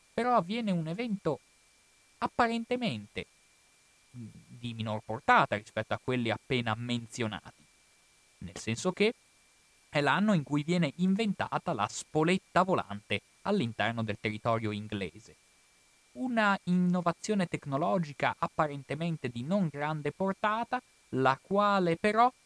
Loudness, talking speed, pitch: -31 LUFS, 105 wpm, 160 Hz